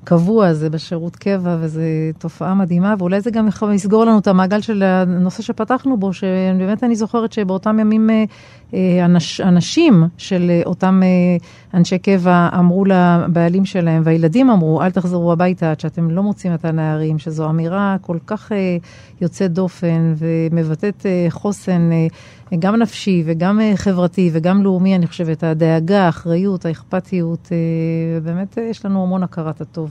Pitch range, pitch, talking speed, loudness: 165-195 Hz, 180 Hz, 135 wpm, -16 LUFS